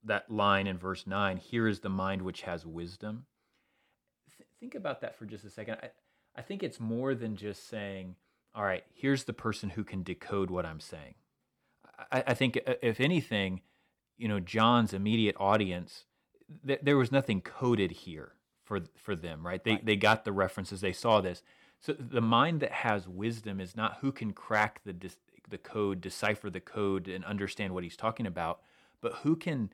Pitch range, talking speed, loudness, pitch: 95-115 Hz, 195 wpm, -32 LUFS, 105 Hz